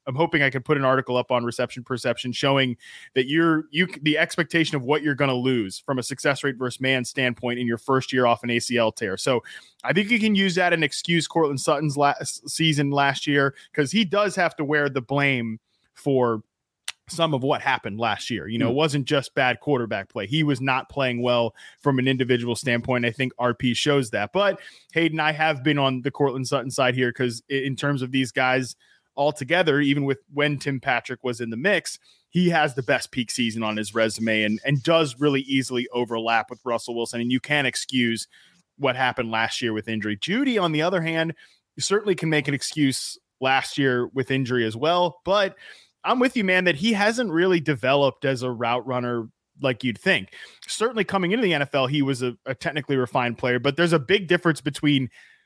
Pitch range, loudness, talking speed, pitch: 125-155 Hz, -23 LUFS, 210 wpm, 135 Hz